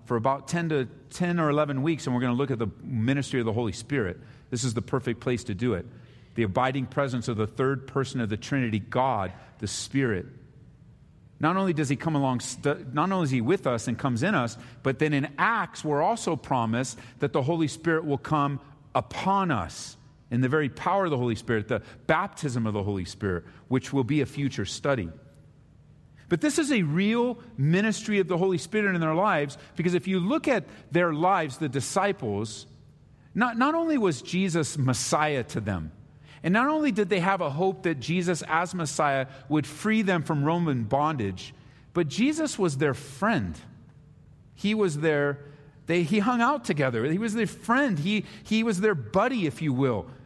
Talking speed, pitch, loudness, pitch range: 195 wpm, 145 Hz, -27 LUFS, 130-180 Hz